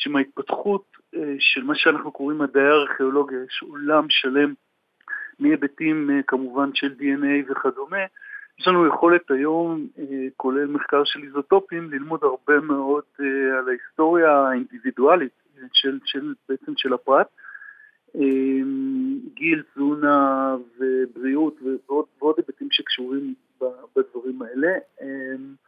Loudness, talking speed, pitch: -22 LUFS, 100 wpm, 145 Hz